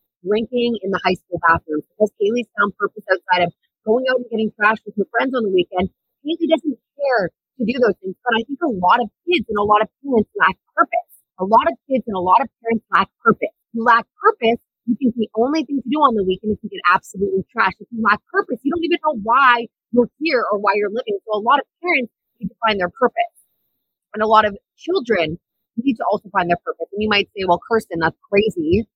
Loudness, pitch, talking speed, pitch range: -19 LUFS, 220 Hz, 245 wpm, 195-250 Hz